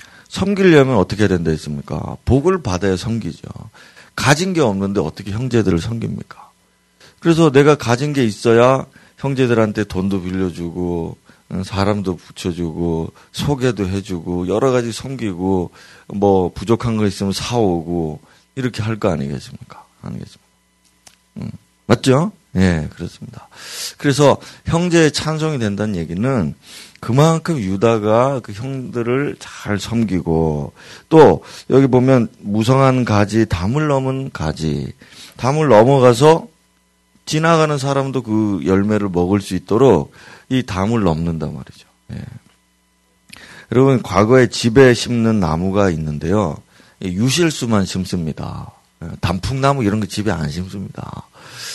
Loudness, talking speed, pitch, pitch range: -16 LUFS, 270 characters per minute, 110 Hz, 95-130 Hz